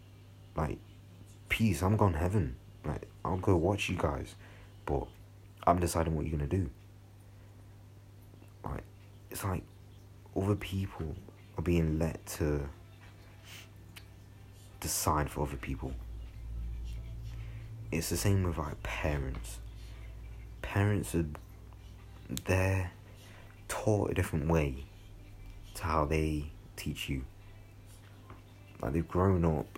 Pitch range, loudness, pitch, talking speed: 85-100 Hz, -34 LUFS, 100 Hz, 110 wpm